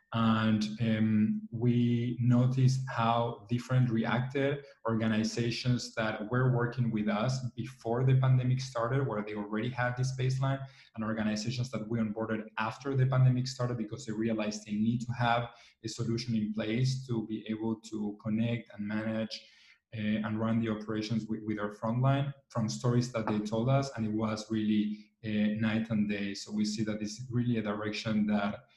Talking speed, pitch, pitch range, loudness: 175 wpm, 115 Hz, 110-120 Hz, -32 LUFS